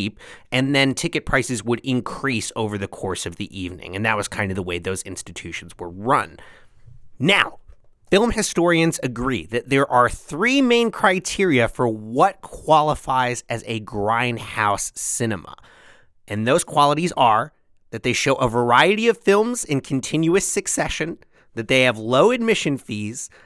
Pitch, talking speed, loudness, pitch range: 125 Hz, 155 wpm, -20 LUFS, 110-155 Hz